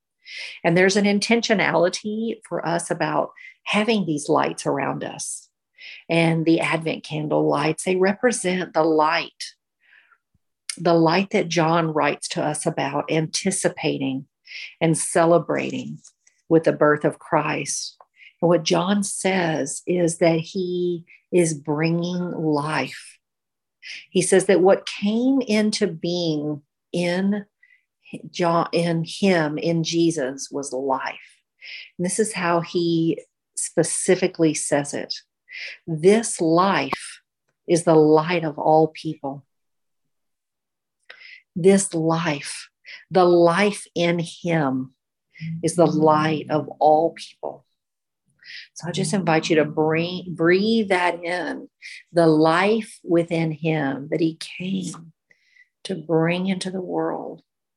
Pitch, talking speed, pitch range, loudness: 170 Hz, 115 wpm, 160-190 Hz, -21 LUFS